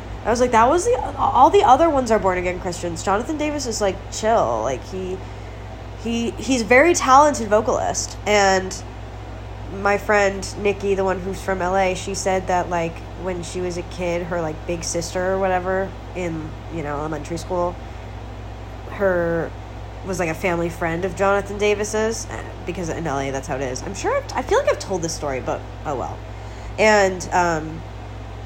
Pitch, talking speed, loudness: 175 Hz, 180 wpm, -20 LUFS